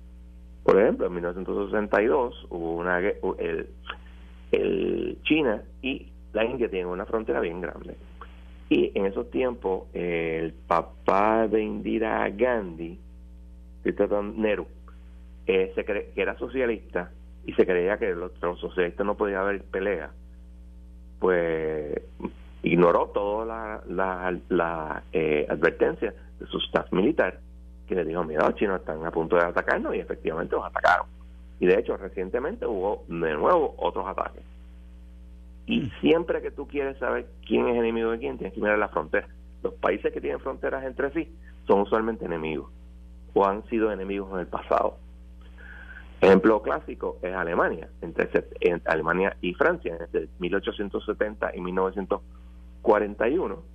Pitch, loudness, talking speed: 80 Hz, -26 LUFS, 145 wpm